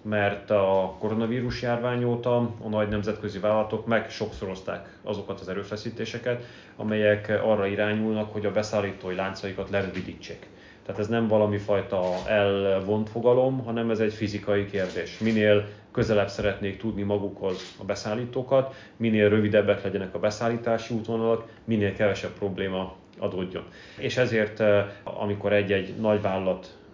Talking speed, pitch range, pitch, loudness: 125 wpm, 100-110 Hz, 105 Hz, -26 LUFS